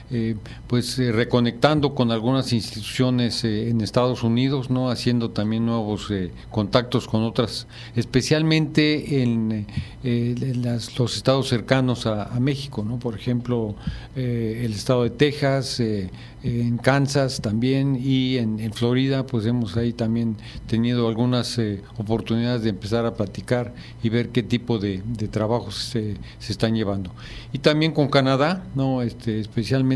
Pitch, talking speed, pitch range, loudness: 120 Hz, 150 wpm, 115-130 Hz, -23 LUFS